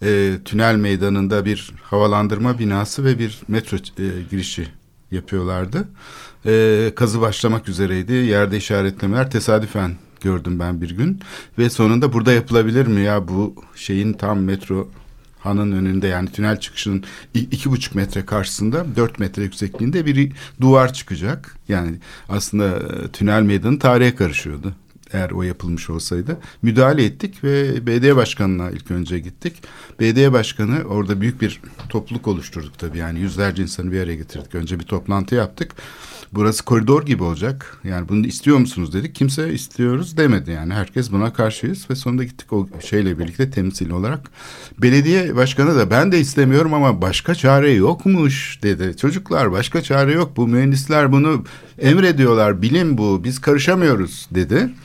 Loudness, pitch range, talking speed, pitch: -18 LUFS, 95-130 Hz, 145 wpm, 110 Hz